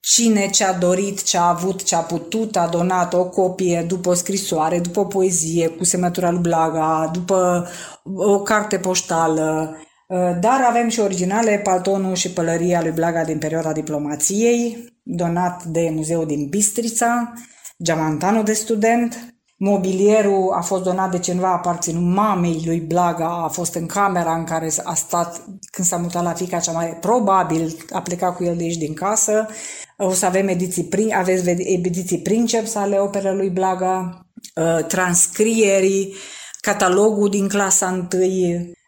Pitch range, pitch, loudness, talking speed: 170-200 Hz, 185 Hz, -19 LUFS, 155 wpm